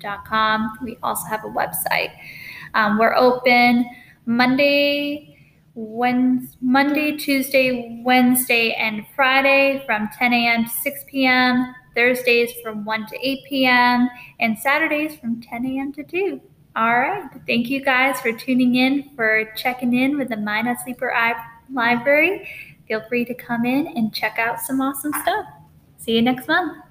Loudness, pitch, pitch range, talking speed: -19 LUFS, 250 Hz, 230-270 Hz, 150 wpm